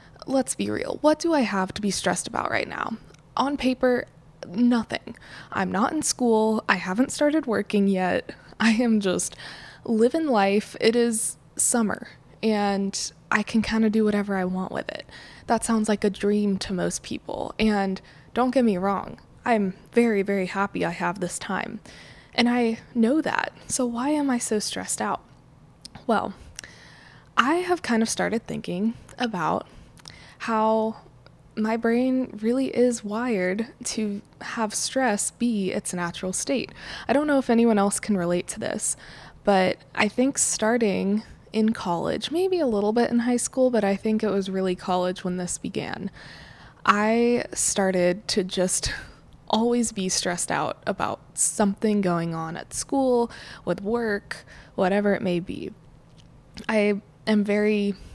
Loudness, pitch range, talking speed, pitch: -24 LUFS, 195-240 Hz, 160 wpm, 215 Hz